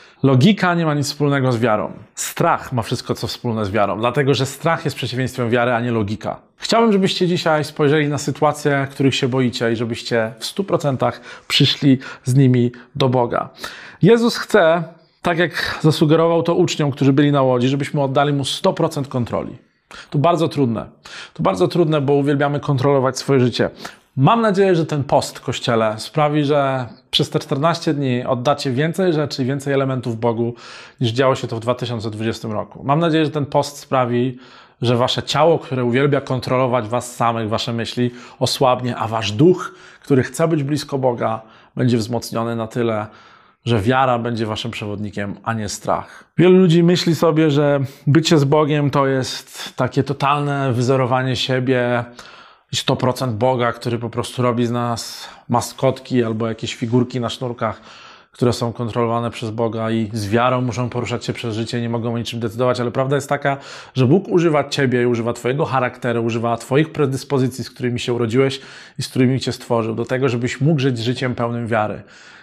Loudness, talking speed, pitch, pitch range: -18 LUFS, 175 wpm, 130 Hz, 120-145 Hz